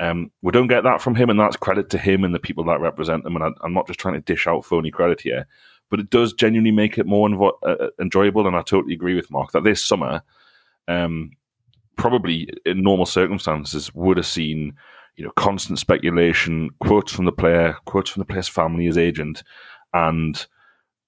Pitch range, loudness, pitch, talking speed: 80-105 Hz, -20 LUFS, 90 Hz, 210 wpm